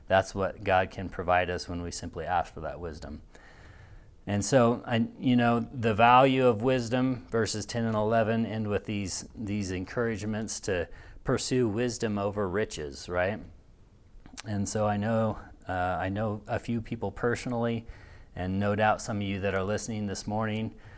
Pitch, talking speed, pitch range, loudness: 105 Hz, 170 wpm, 95-115 Hz, -29 LUFS